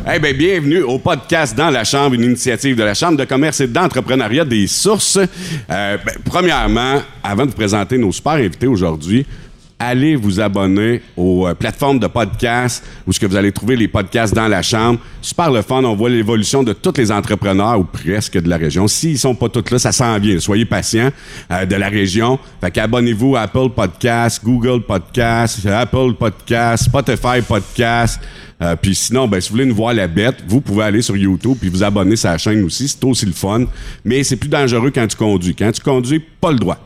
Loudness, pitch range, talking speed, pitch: -15 LUFS, 100-130 Hz, 210 wpm, 115 Hz